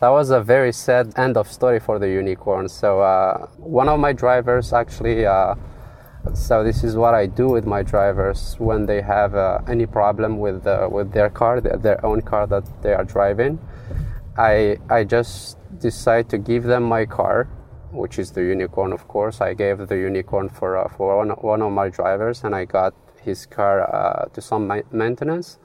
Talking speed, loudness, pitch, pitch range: 190 wpm, -20 LUFS, 110 Hz, 100-120 Hz